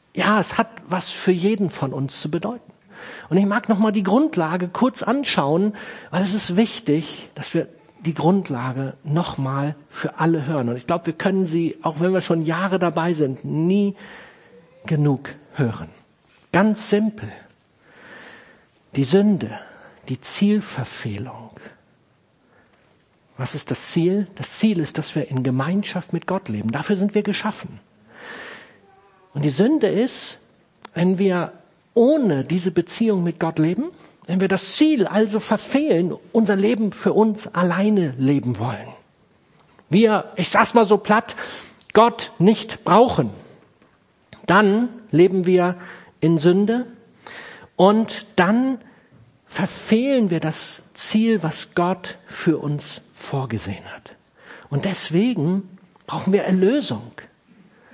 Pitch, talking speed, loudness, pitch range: 185 Hz, 135 wpm, -20 LUFS, 160-215 Hz